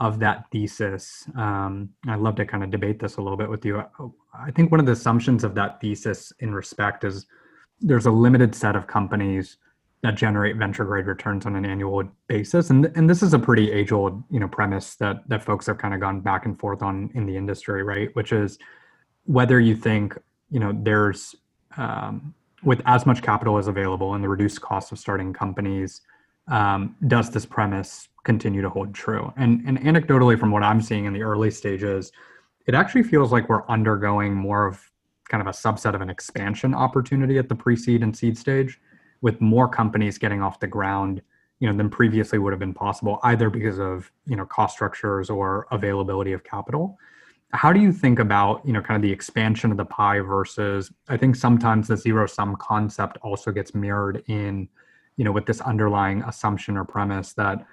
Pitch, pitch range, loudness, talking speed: 105 Hz, 100-115 Hz, -22 LUFS, 200 wpm